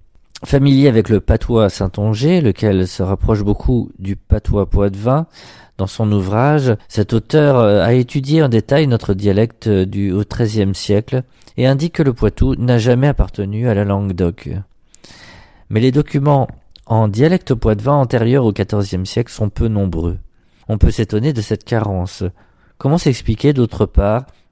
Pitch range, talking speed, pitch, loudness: 100-130 Hz, 150 wpm, 110 Hz, -16 LUFS